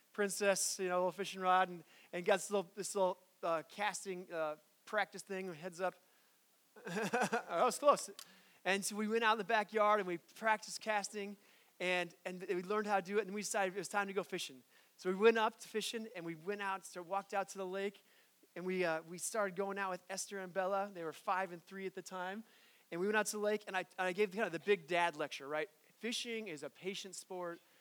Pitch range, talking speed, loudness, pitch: 180-210 Hz, 240 wpm, -38 LUFS, 195 Hz